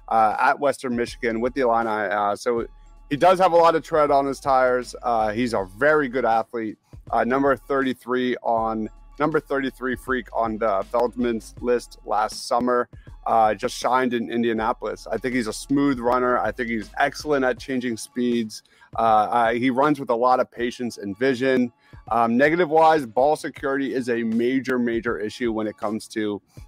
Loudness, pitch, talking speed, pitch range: -22 LUFS, 120 Hz, 180 wpm, 115-135 Hz